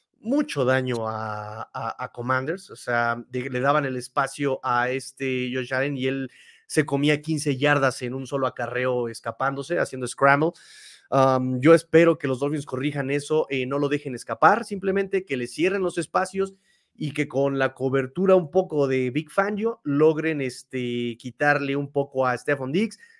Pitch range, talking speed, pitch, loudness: 130-155 Hz, 175 wpm, 140 Hz, -24 LUFS